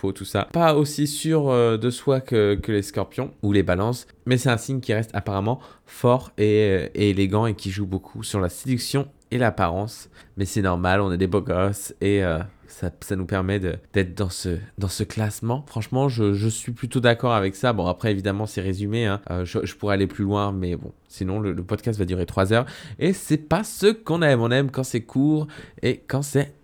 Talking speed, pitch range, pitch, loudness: 225 wpm, 95-125 Hz, 105 Hz, -23 LUFS